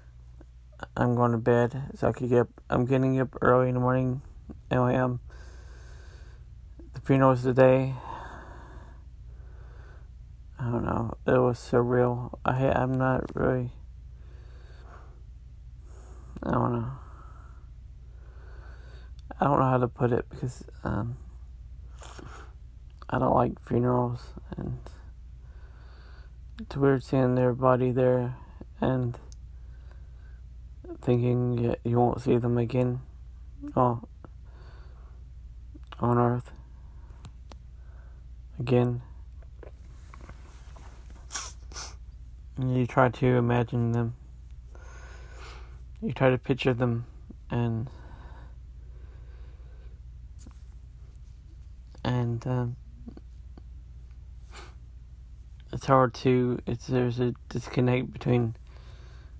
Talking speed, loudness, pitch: 90 wpm, -27 LUFS, 80 Hz